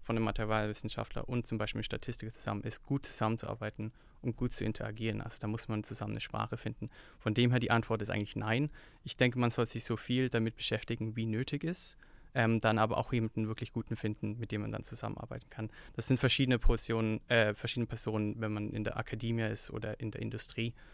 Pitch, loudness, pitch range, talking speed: 115 Hz, -35 LUFS, 110-120 Hz, 210 wpm